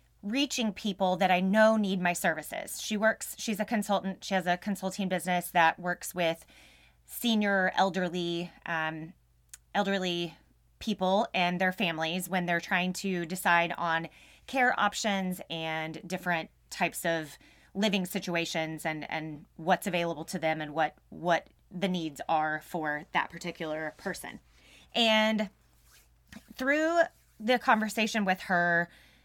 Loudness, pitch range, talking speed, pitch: -30 LUFS, 165-205 Hz, 135 wpm, 180 Hz